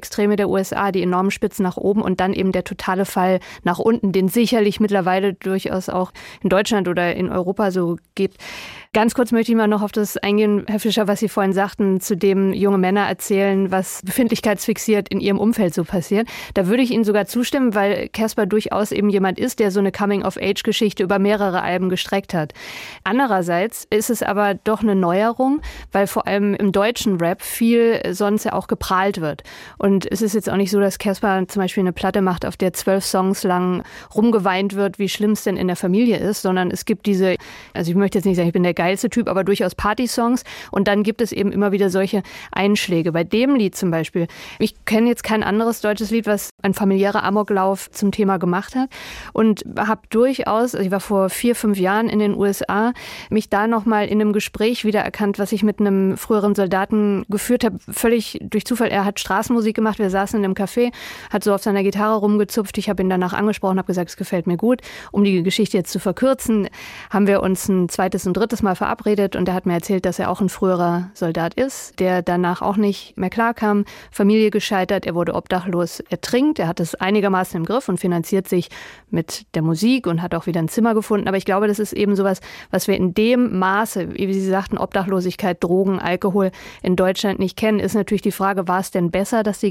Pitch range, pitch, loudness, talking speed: 190-215 Hz, 200 Hz, -19 LUFS, 215 wpm